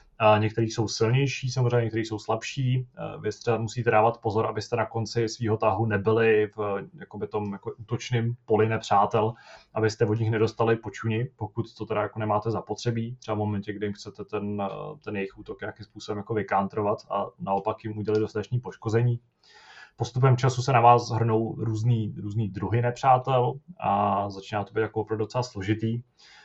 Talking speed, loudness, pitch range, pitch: 165 wpm, -26 LUFS, 105-120 Hz, 110 Hz